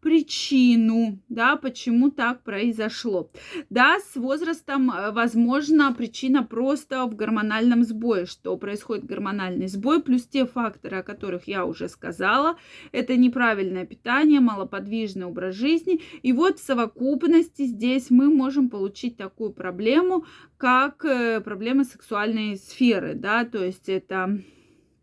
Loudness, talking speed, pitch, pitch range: -23 LUFS, 120 wpm, 240 Hz, 210-275 Hz